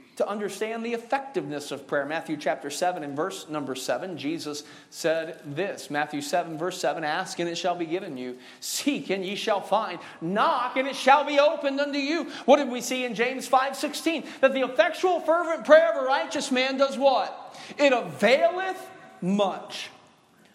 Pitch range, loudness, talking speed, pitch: 170-285 Hz, -25 LUFS, 180 wpm, 235 Hz